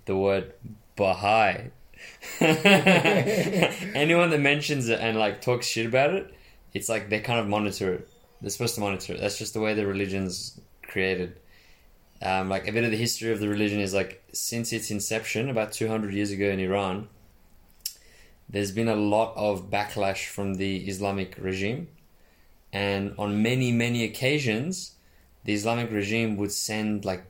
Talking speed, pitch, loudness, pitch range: 165 wpm, 105 Hz, -26 LUFS, 95-115 Hz